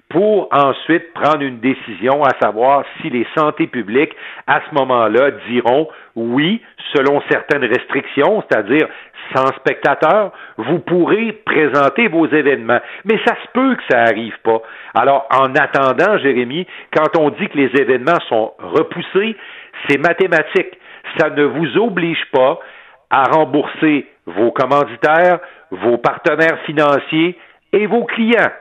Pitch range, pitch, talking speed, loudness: 135-175 Hz, 155 Hz, 135 wpm, -15 LUFS